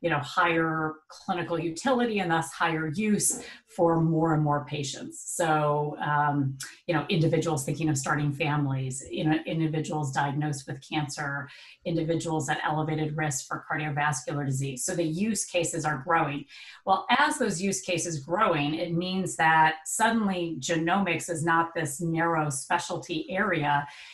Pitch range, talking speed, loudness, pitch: 150-175 Hz, 145 wpm, -27 LUFS, 160 Hz